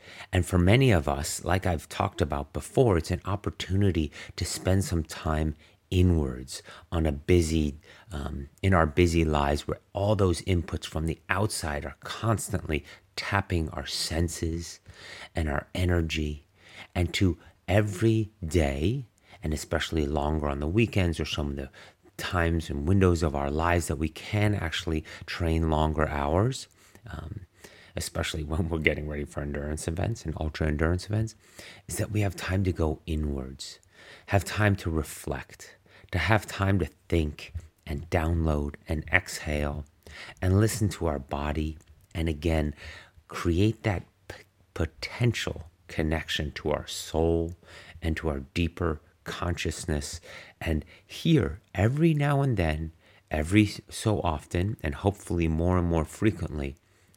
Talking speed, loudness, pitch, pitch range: 145 wpm, -28 LUFS, 85 Hz, 80-95 Hz